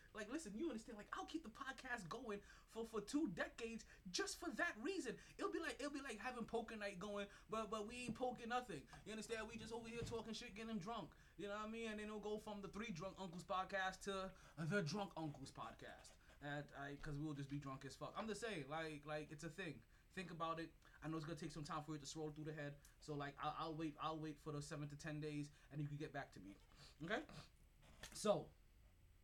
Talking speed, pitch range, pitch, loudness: 245 wpm, 150-225 Hz, 190 Hz, -50 LUFS